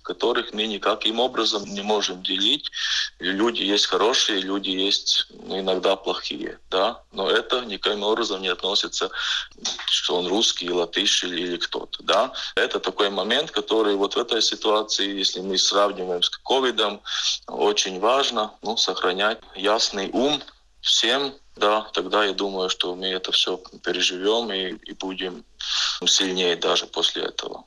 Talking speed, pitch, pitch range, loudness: 140 wpm, 95 Hz, 95-105 Hz, -22 LUFS